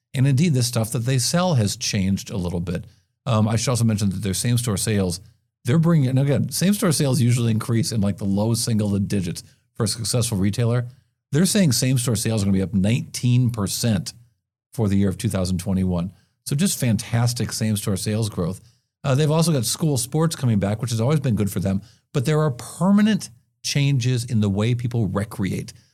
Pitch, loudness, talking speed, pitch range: 115 Hz, -21 LUFS, 205 wpm, 105-130 Hz